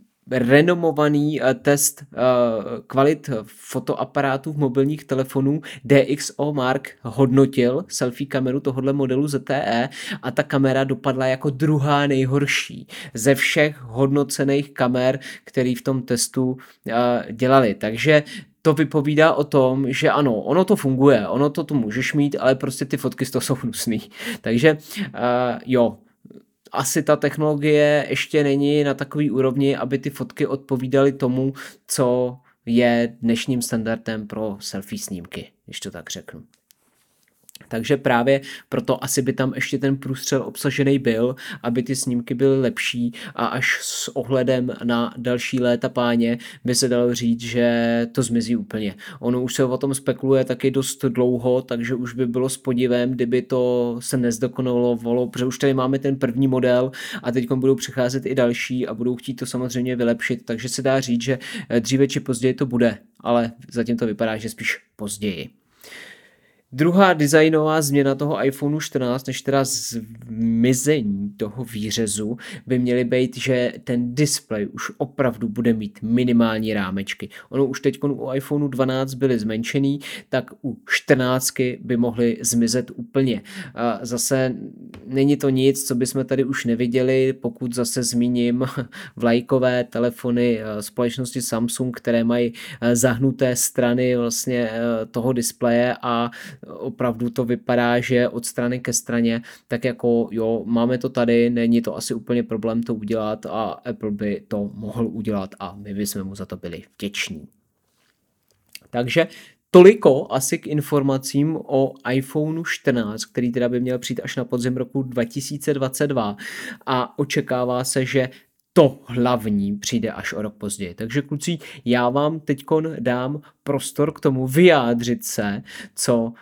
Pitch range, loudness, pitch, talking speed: 120-140 Hz, -21 LUFS, 130 Hz, 145 wpm